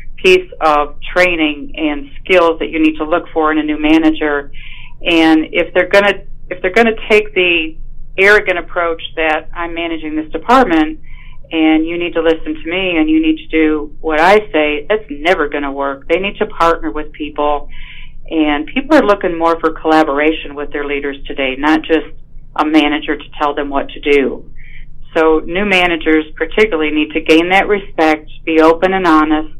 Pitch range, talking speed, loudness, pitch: 150-175 Hz, 180 wpm, -13 LUFS, 155 Hz